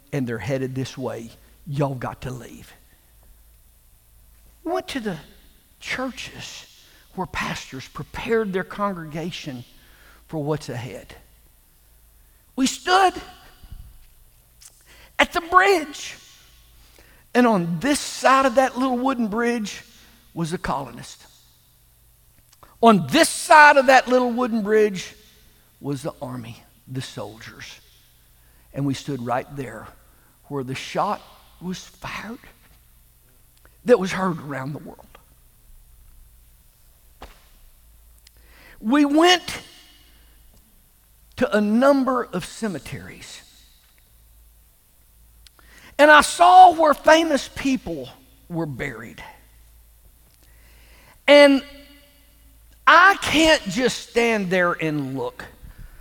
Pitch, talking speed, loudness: 165 Hz, 95 wpm, -19 LUFS